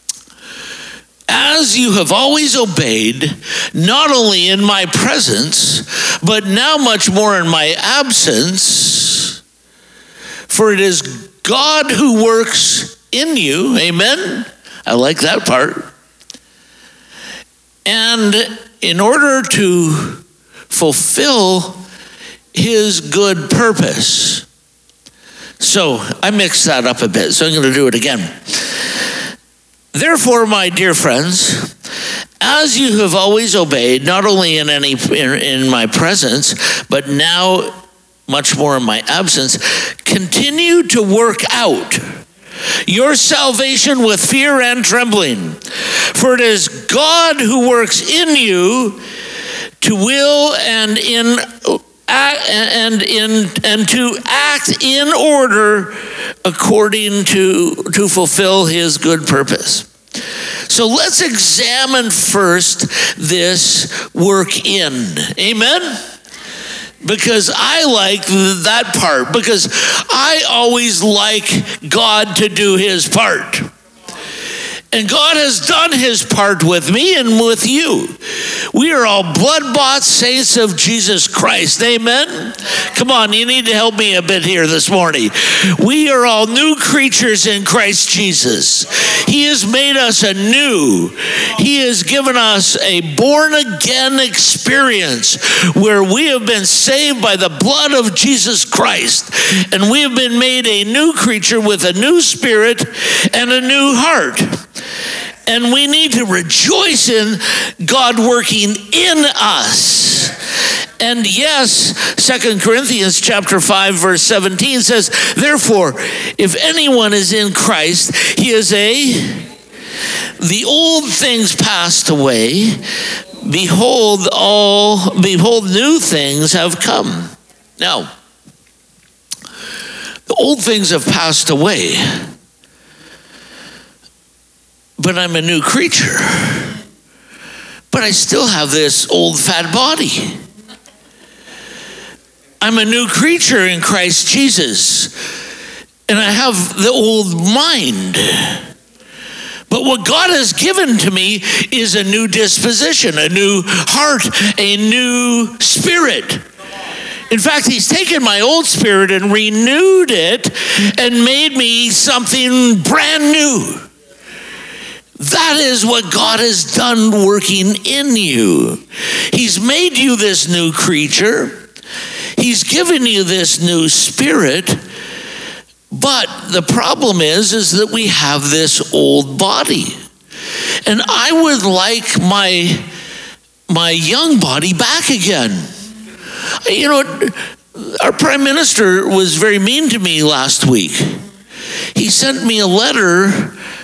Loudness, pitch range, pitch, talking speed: -10 LUFS, 190-255 Hz, 215 Hz, 120 wpm